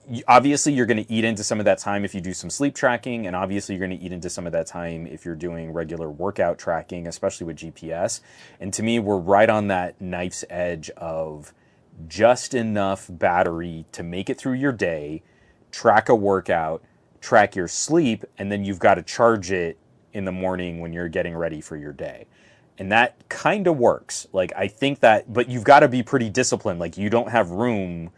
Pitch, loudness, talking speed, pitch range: 95 Hz, -22 LUFS, 210 wpm, 85-115 Hz